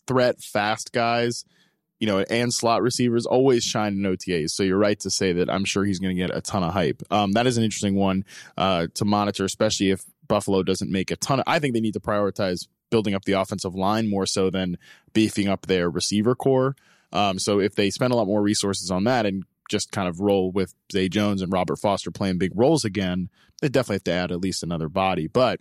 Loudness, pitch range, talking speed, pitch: -23 LUFS, 95-110 Hz, 235 wpm, 100 Hz